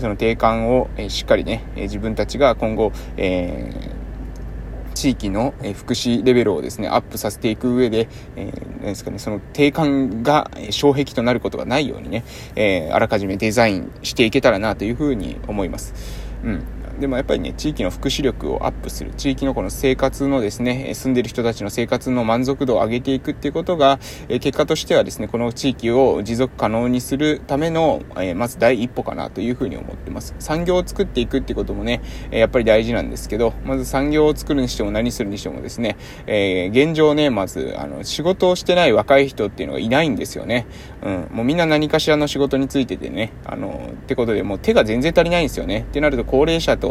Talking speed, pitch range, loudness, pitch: 415 characters per minute, 110-140 Hz, -19 LUFS, 125 Hz